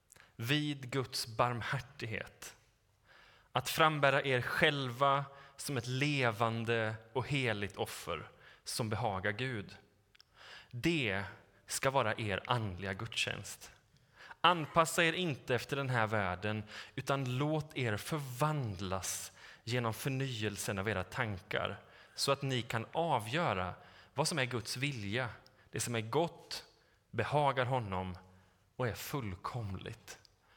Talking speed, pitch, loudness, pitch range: 110 wpm, 120 Hz, -35 LUFS, 105-140 Hz